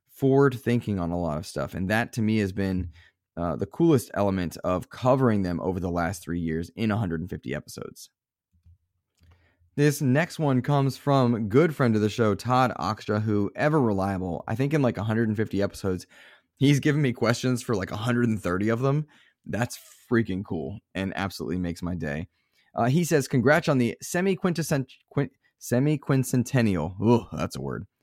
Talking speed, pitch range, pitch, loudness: 170 wpm, 90-130 Hz, 110 Hz, -26 LUFS